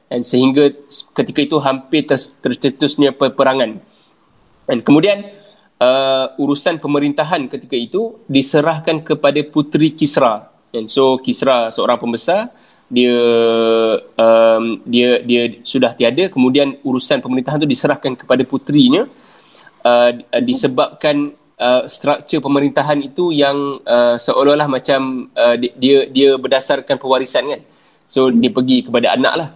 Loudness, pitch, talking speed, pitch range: -14 LUFS, 135 Hz, 120 wpm, 125-145 Hz